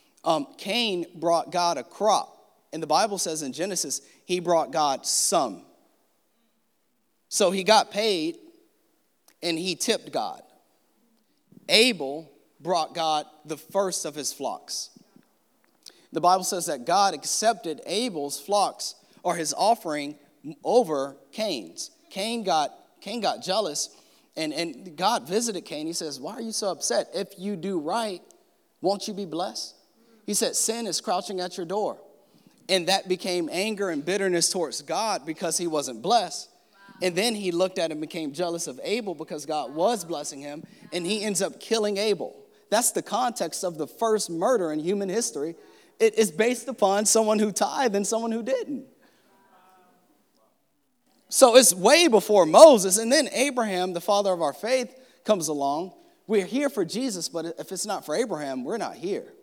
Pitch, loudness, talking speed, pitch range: 200 Hz, -25 LUFS, 160 wpm, 175-230 Hz